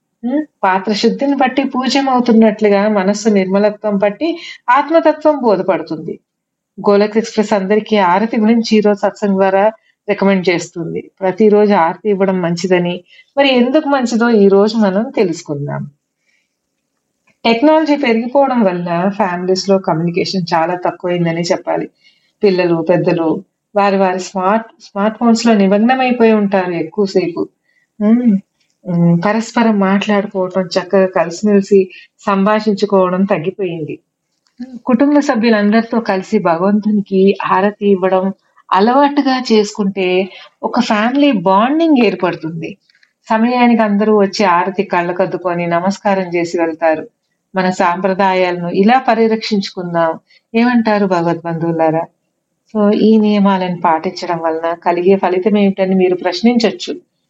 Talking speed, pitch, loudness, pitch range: 100 wpm, 200 Hz, -13 LUFS, 185-225 Hz